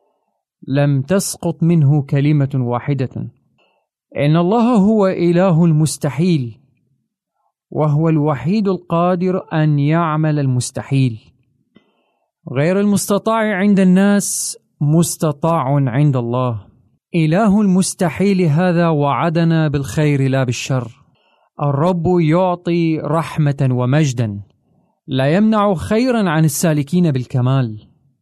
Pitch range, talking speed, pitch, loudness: 135-180 Hz, 85 wpm, 155 Hz, -16 LUFS